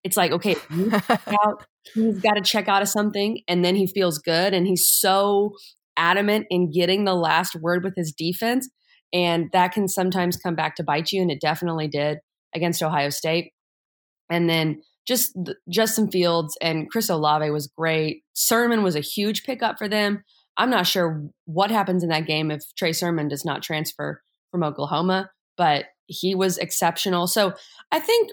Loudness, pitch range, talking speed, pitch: -22 LUFS, 165-205 Hz, 175 wpm, 180 Hz